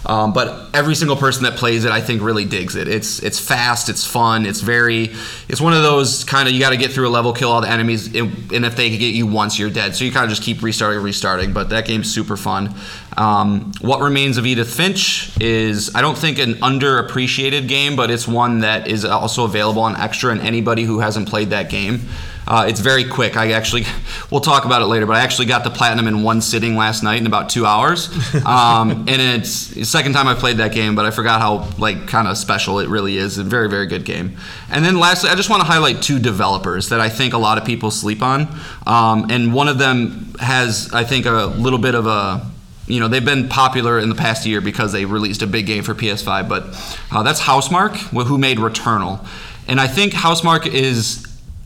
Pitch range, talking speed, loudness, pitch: 110-130 Hz, 235 wpm, -16 LUFS, 115 Hz